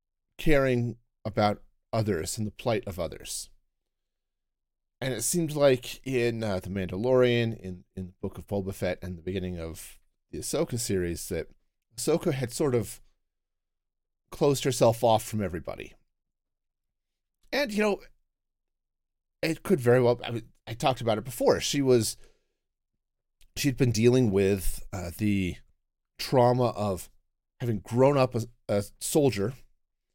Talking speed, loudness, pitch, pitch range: 140 wpm, -28 LUFS, 105 Hz, 90-125 Hz